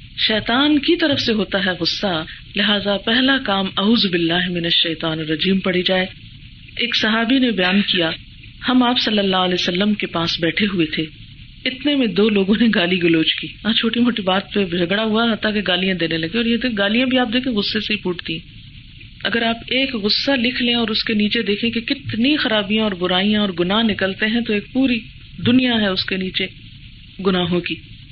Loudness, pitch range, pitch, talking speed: -18 LUFS, 175-230 Hz, 205 Hz, 190 wpm